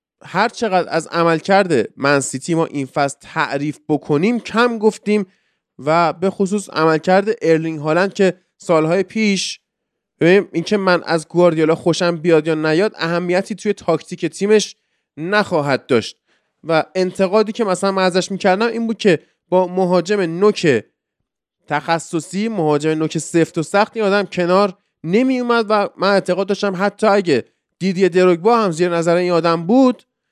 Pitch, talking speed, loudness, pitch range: 185 Hz, 155 wpm, -17 LUFS, 165-205 Hz